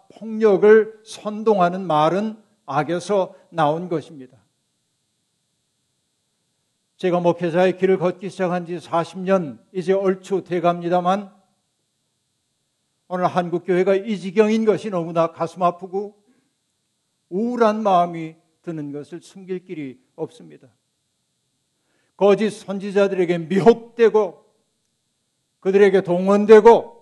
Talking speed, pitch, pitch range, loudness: 225 characters per minute, 185 Hz, 170-205 Hz, -19 LUFS